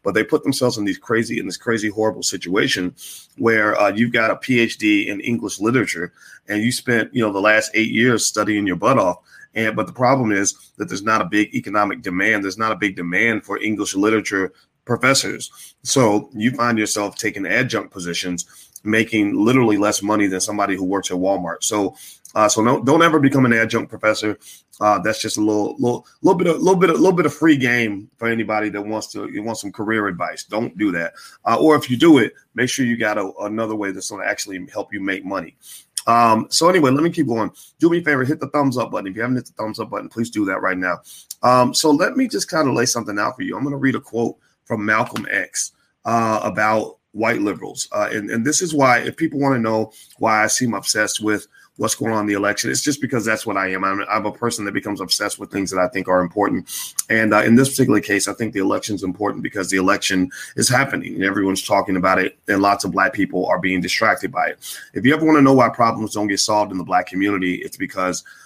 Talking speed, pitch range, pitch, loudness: 245 wpm, 100-120 Hz, 110 Hz, -19 LUFS